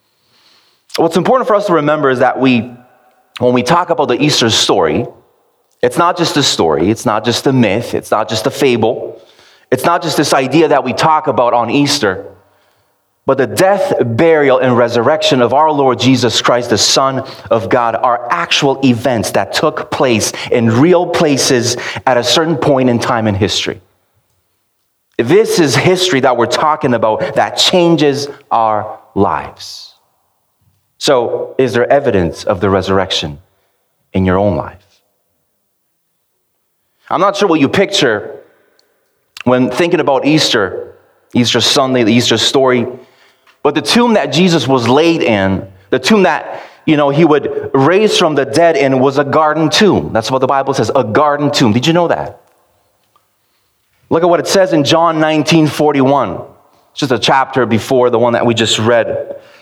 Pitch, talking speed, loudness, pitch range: 135 Hz, 165 wpm, -12 LUFS, 120-165 Hz